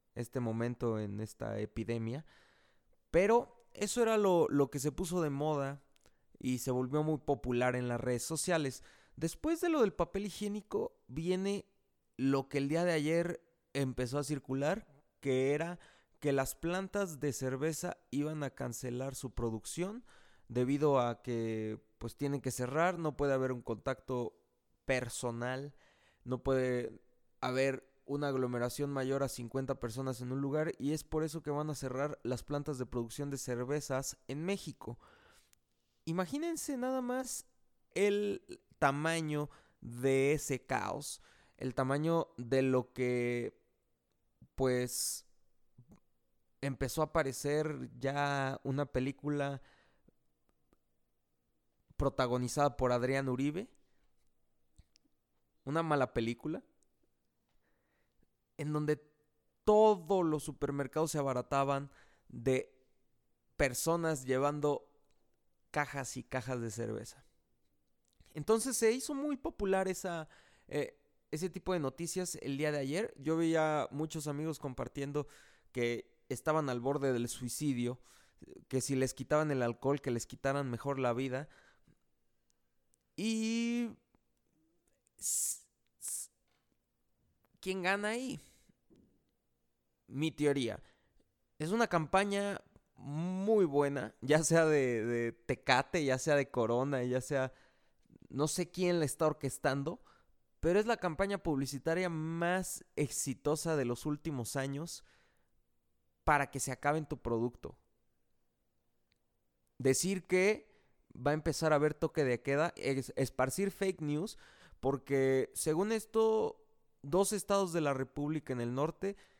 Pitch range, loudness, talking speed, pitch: 125-160 Hz, -35 LUFS, 120 wpm, 140 Hz